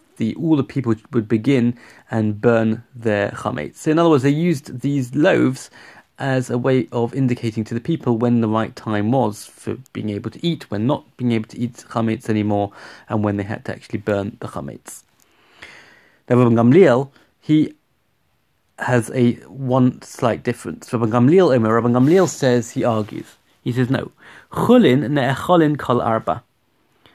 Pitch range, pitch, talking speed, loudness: 110-130 Hz, 120 Hz, 155 wpm, -19 LUFS